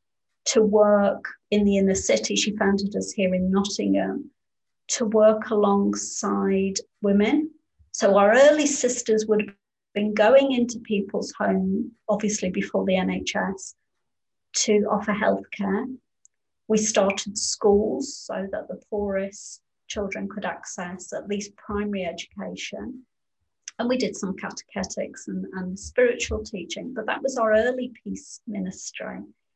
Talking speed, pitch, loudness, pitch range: 130 wpm, 210 Hz, -24 LUFS, 195-225 Hz